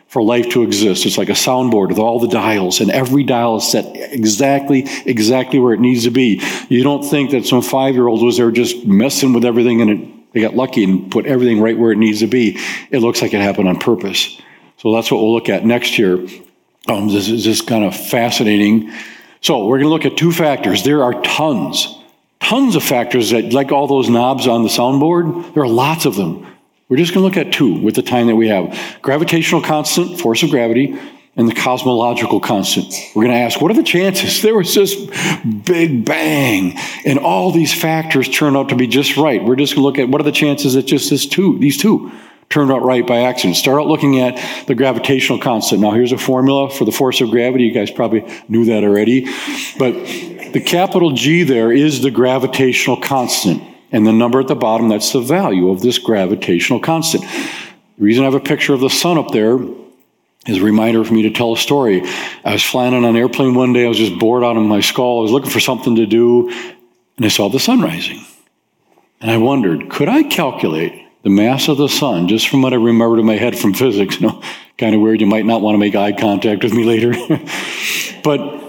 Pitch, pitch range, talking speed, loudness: 125 Hz, 115-140 Hz, 225 wpm, -13 LUFS